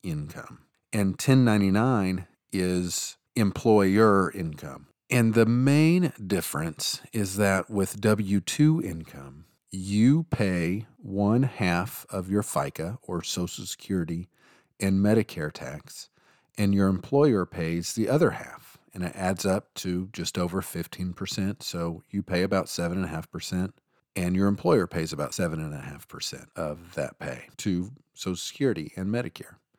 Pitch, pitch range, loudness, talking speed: 95 Hz, 90-110 Hz, -26 LUFS, 125 wpm